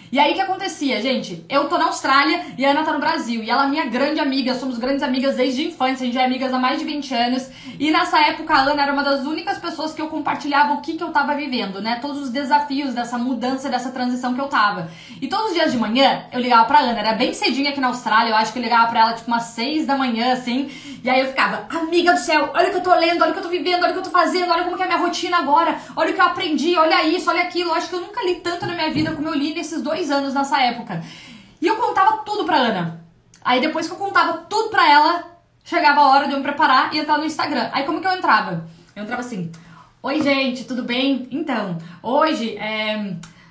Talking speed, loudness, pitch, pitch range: 270 wpm, -19 LUFS, 285 Hz, 250-330 Hz